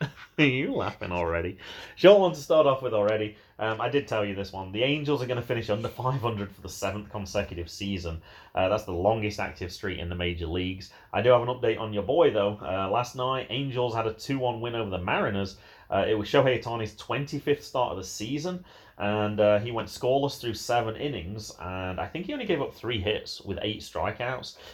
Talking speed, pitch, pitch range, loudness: 220 wpm, 105 Hz, 100-125 Hz, -28 LUFS